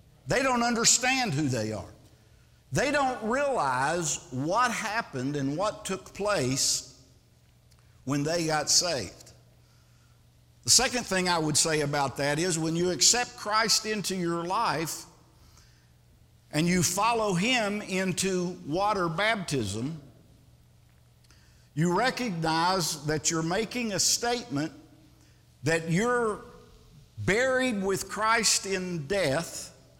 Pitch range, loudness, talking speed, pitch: 140-215 Hz, -26 LUFS, 110 wpm, 175 Hz